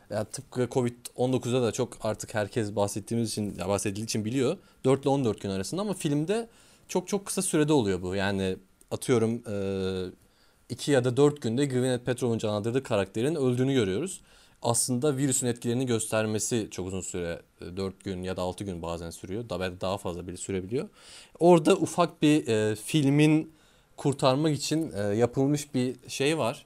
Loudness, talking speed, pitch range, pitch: -28 LUFS, 155 wpm, 100-140 Hz, 120 Hz